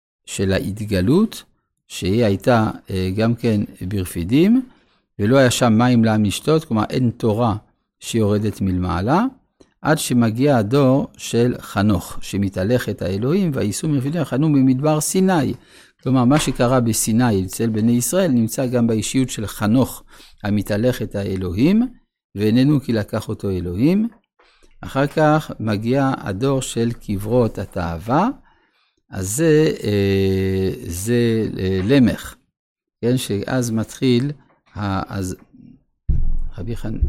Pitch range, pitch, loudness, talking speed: 100-135 Hz, 115 Hz, -19 LUFS, 105 wpm